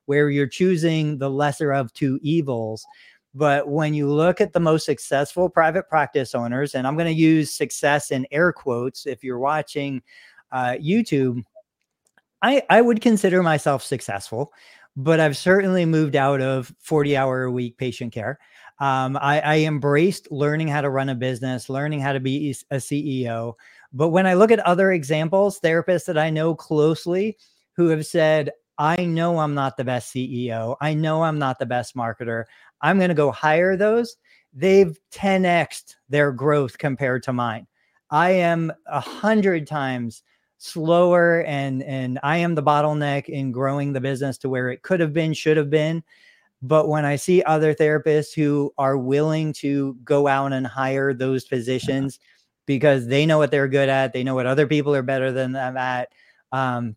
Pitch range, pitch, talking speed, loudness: 135-160 Hz, 145 Hz, 175 wpm, -21 LUFS